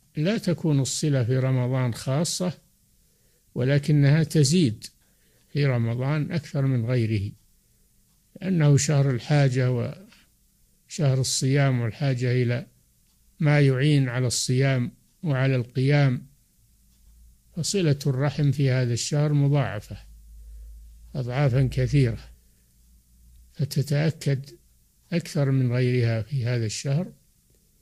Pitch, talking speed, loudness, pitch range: 135 Hz, 90 wpm, -24 LUFS, 120-145 Hz